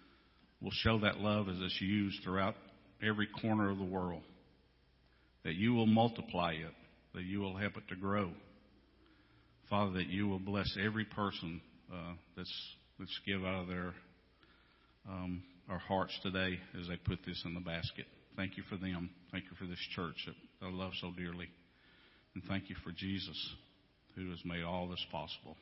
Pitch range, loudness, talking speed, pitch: 90-100 Hz, -39 LUFS, 175 wpm, 95 Hz